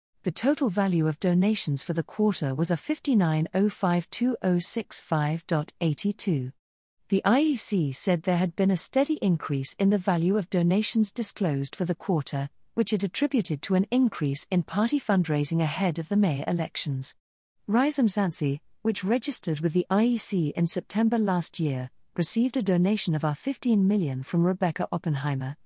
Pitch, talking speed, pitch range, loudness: 180 Hz, 150 wpm, 160-210 Hz, -26 LUFS